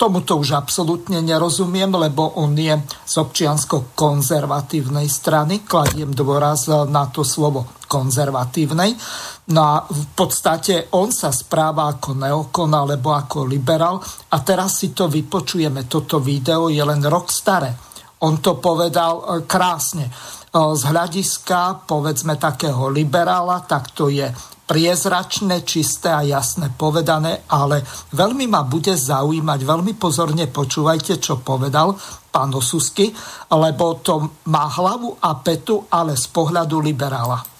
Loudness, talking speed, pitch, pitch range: -18 LUFS, 125 wpm, 155 Hz, 145-175 Hz